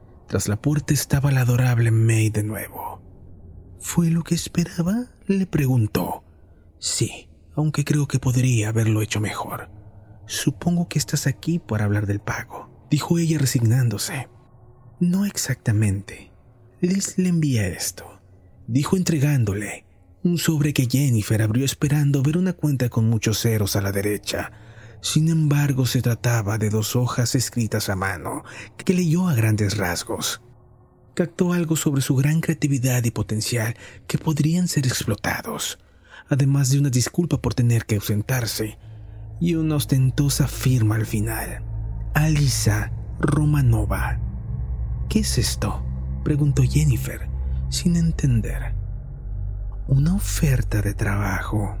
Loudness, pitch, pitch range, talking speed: -22 LUFS, 120 Hz, 105-145 Hz, 130 wpm